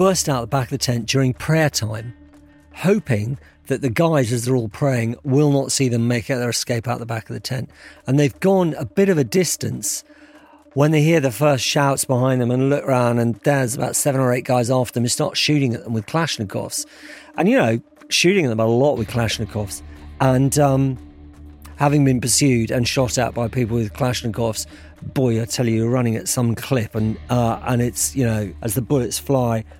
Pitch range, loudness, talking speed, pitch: 115-145 Hz, -19 LUFS, 215 wpm, 125 Hz